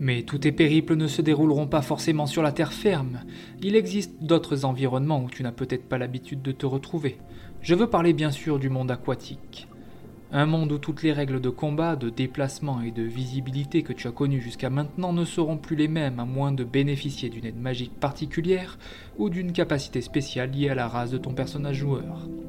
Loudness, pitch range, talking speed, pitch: -26 LUFS, 130-155 Hz, 210 wpm, 140 Hz